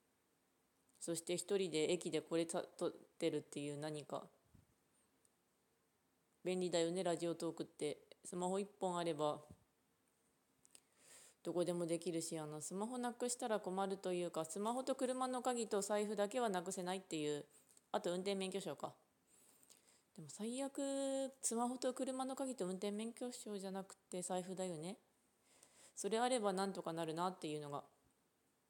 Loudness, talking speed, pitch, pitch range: -43 LUFS, 300 characters per minute, 185 Hz, 165-225 Hz